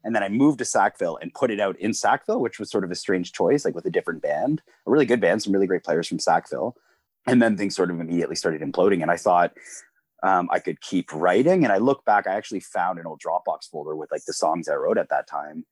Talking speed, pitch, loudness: 265 wpm, 120 Hz, -23 LUFS